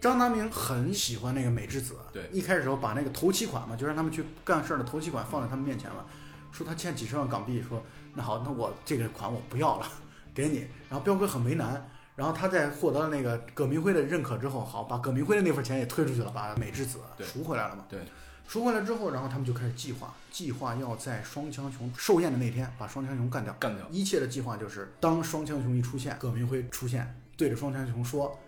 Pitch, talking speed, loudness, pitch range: 135 Hz, 360 characters per minute, -31 LUFS, 120-150 Hz